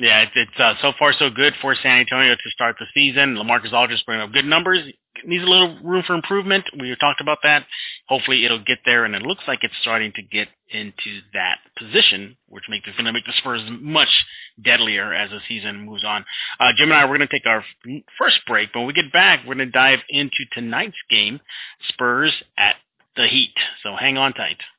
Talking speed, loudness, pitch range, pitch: 225 wpm, -17 LUFS, 115-145 Hz, 130 Hz